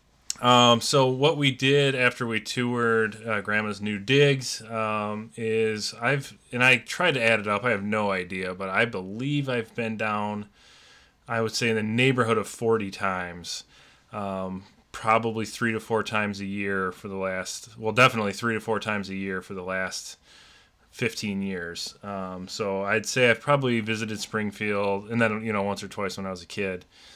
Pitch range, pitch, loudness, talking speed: 100-115 Hz, 110 Hz, -25 LUFS, 190 wpm